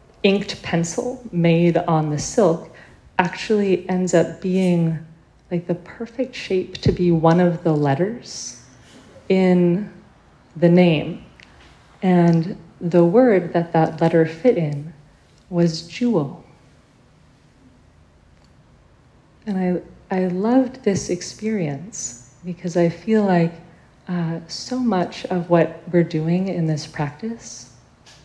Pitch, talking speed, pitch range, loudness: 170 Hz, 115 wpm, 160-185 Hz, -20 LUFS